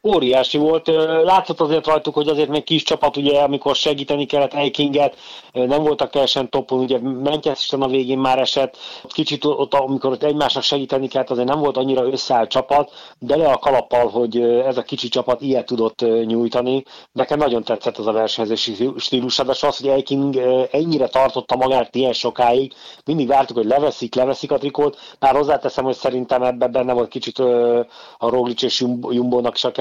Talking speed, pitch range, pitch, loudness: 175 wpm, 125-145 Hz, 135 Hz, -18 LUFS